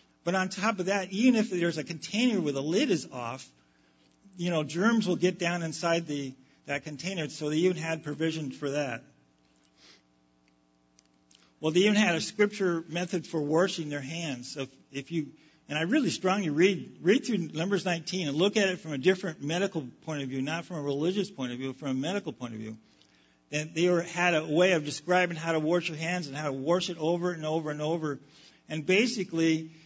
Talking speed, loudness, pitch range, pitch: 215 wpm, -29 LUFS, 140-180 Hz, 160 Hz